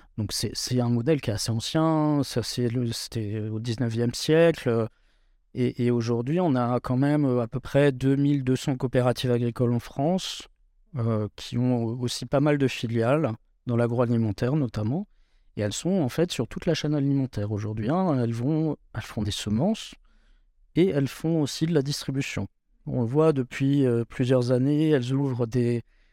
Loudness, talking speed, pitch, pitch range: -26 LUFS, 175 wpm, 125 Hz, 120-145 Hz